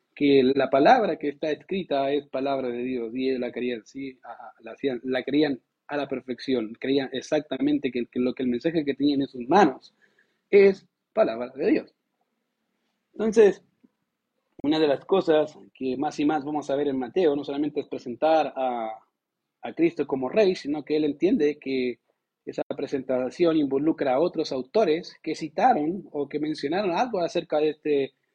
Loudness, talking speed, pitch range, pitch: -25 LUFS, 175 wpm, 130-165 Hz, 145 Hz